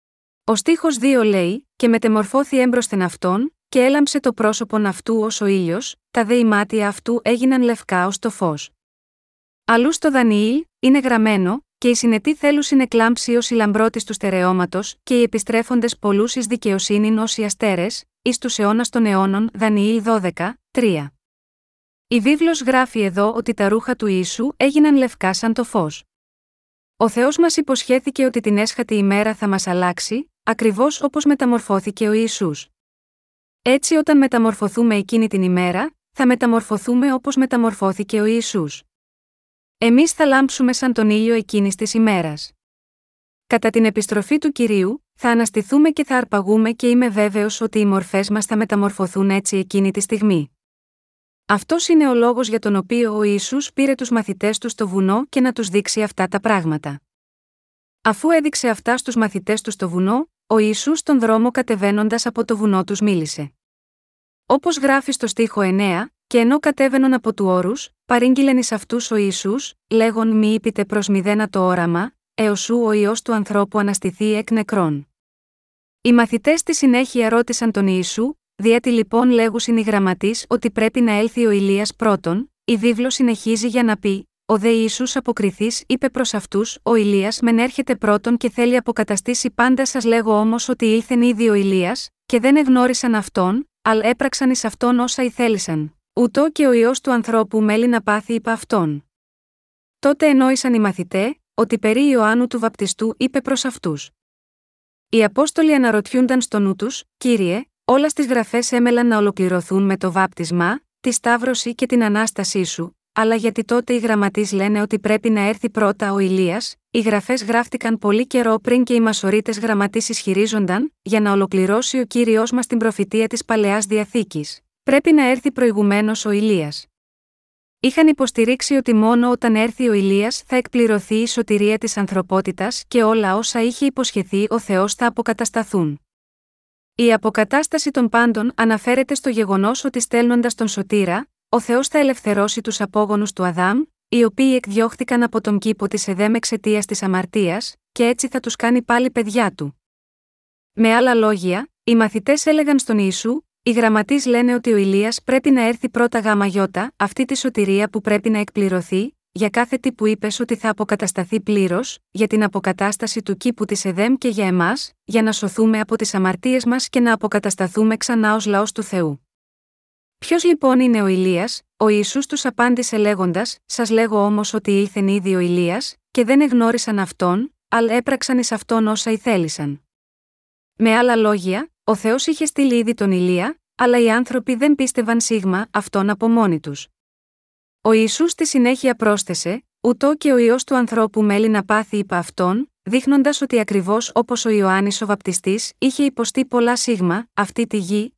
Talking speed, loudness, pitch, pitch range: 165 wpm, -18 LUFS, 225 Hz, 205-245 Hz